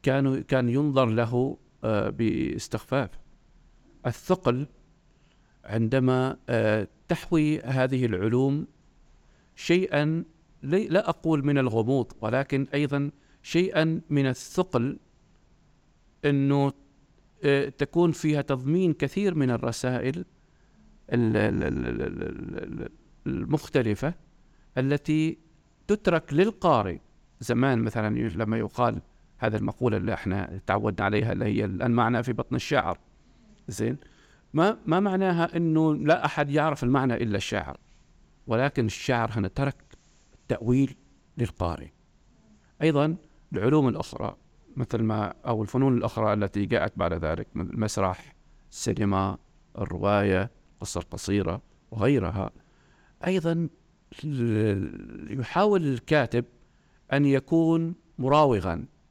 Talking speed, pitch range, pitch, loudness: 90 wpm, 110-150 Hz, 130 Hz, -26 LUFS